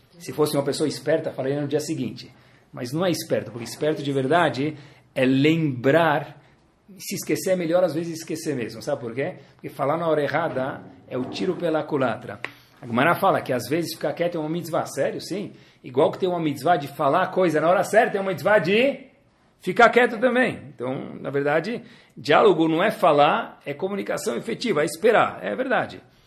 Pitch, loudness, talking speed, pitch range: 160 Hz, -23 LUFS, 195 wpm, 140-185 Hz